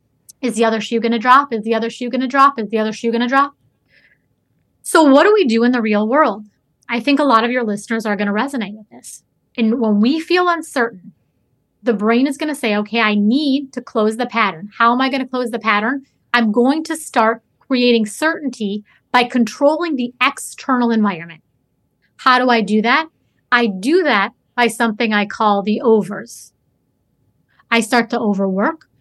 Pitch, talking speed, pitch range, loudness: 235 Hz, 205 wpm, 215-265 Hz, -16 LUFS